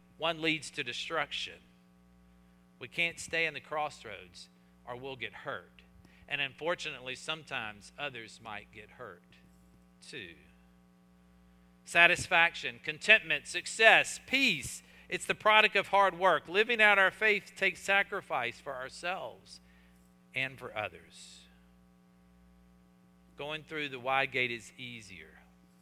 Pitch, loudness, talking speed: 125 Hz, -29 LUFS, 115 wpm